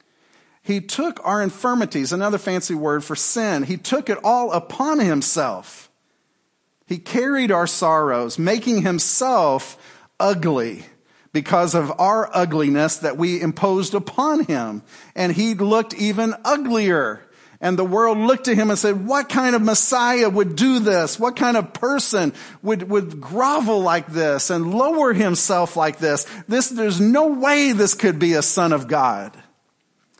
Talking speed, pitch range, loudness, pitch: 150 wpm, 175-240 Hz, -19 LUFS, 205 Hz